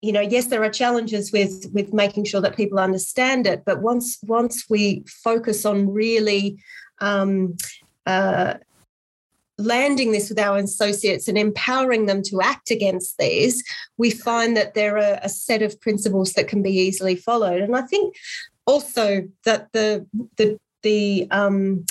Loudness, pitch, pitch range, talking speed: -21 LUFS, 210 Hz, 195-230 Hz, 160 wpm